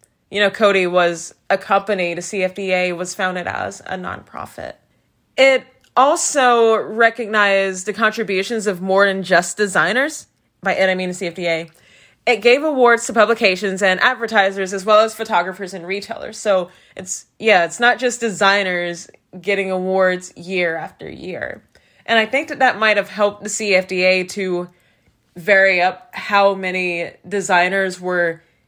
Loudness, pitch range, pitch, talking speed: -17 LUFS, 185-220 Hz, 195 Hz, 150 wpm